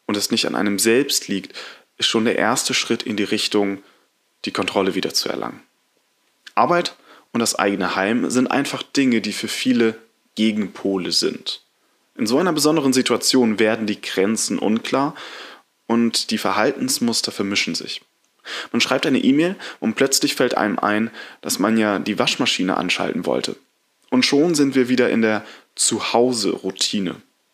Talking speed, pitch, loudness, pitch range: 155 wpm, 115 Hz, -19 LUFS, 105-135 Hz